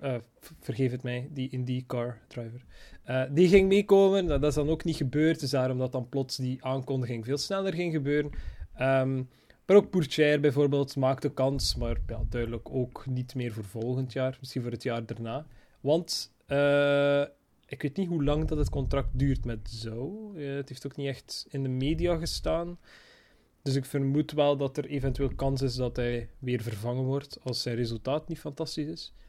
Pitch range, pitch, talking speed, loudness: 125-150 Hz, 135 Hz, 190 wpm, -29 LUFS